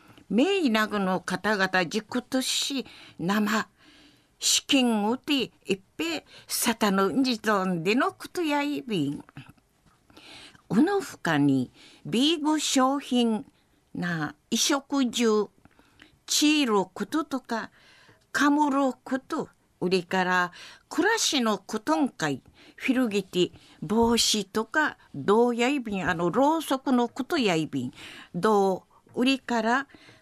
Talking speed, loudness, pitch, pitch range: 220 characters per minute, -26 LUFS, 235 Hz, 195-275 Hz